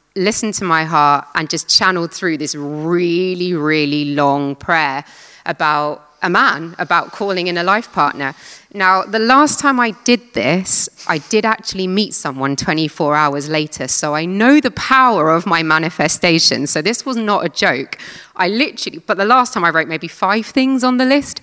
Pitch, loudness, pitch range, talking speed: 170 Hz, -15 LUFS, 150-215 Hz, 180 wpm